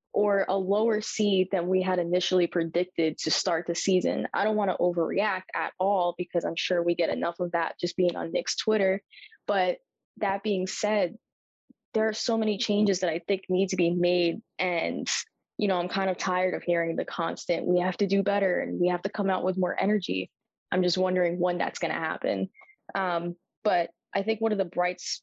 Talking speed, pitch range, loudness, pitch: 215 wpm, 175-200 Hz, -27 LUFS, 185 Hz